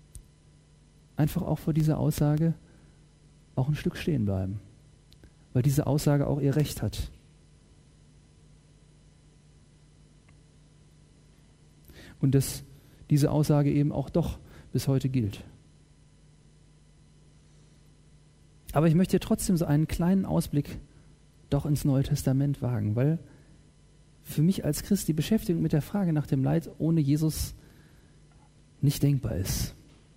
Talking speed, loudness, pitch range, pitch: 115 wpm, -27 LUFS, 135-155 Hz, 145 Hz